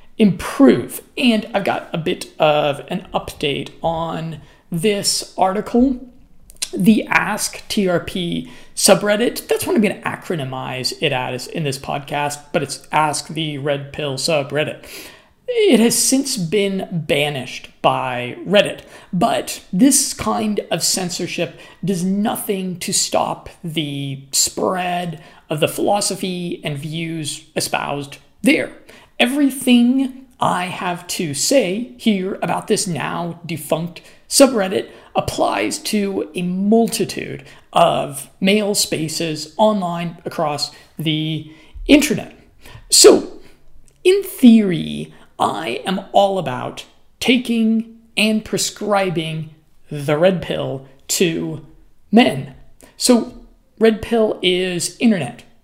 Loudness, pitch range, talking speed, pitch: -18 LUFS, 155-215 Hz, 110 wpm, 180 Hz